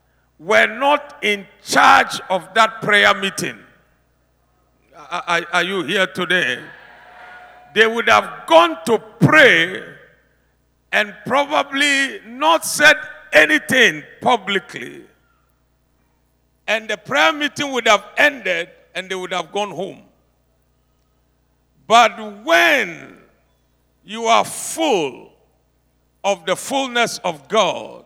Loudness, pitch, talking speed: -16 LUFS, 190 Hz, 105 wpm